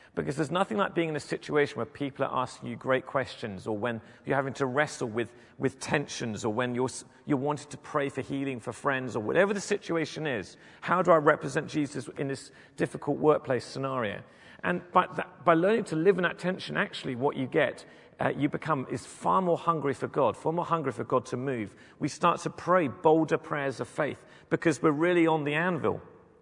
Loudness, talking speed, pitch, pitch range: -29 LUFS, 215 wpm, 145 Hz, 130-165 Hz